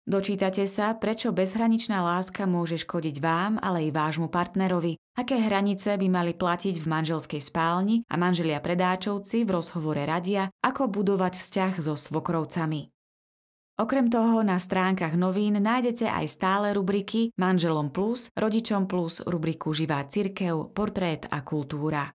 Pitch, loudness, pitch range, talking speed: 185 Hz, -27 LUFS, 165-205 Hz, 135 wpm